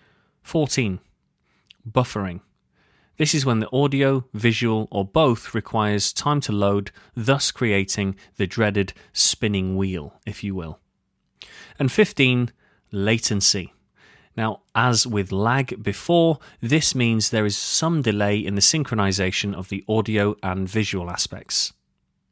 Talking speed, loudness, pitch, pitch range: 125 wpm, -21 LUFS, 110 Hz, 100-125 Hz